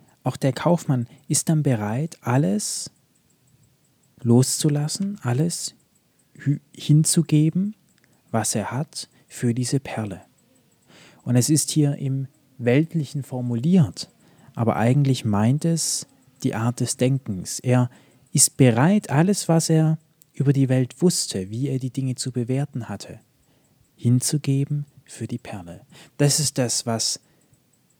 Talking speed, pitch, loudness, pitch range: 120 wpm, 135 Hz, -22 LUFS, 125-155 Hz